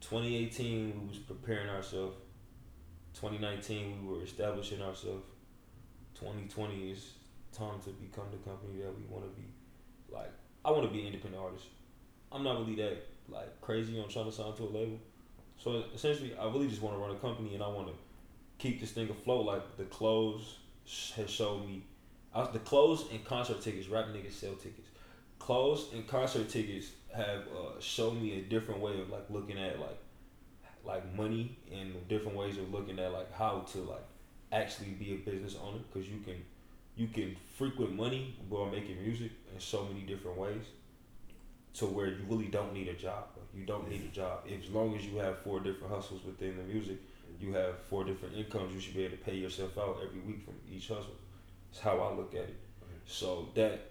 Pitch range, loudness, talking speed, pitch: 95-110 Hz, -39 LUFS, 200 wpm, 100 Hz